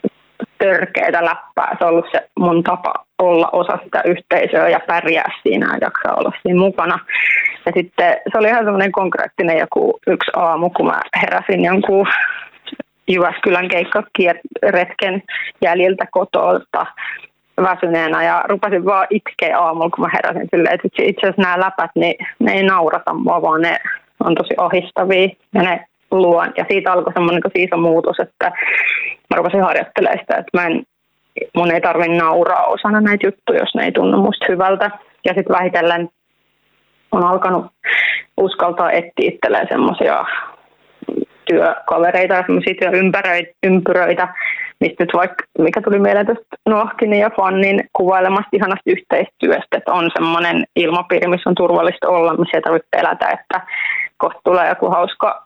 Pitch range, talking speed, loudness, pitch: 175-205 Hz, 145 wpm, -15 LUFS, 185 Hz